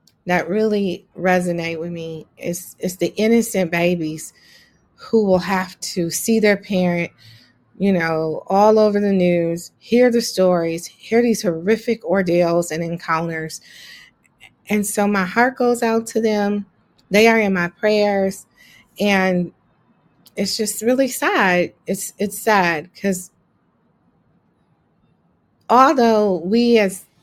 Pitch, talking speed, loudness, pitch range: 190 Hz, 125 wpm, -18 LUFS, 175-215 Hz